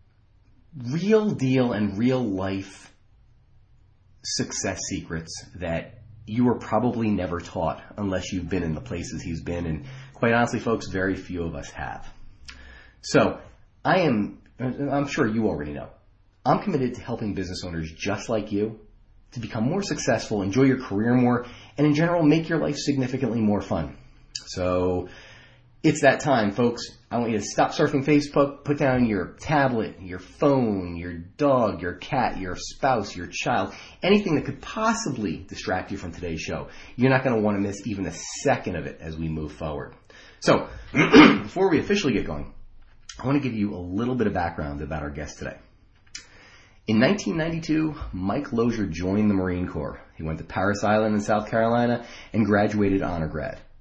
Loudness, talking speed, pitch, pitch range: -24 LUFS, 175 wpm, 105 Hz, 90-125 Hz